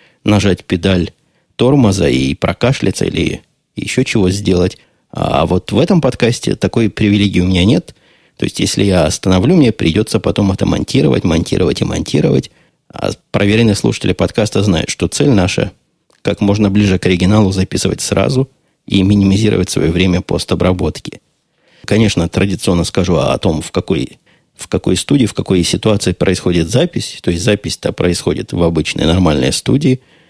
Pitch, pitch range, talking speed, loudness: 95 Hz, 90-110 Hz, 150 wpm, -13 LUFS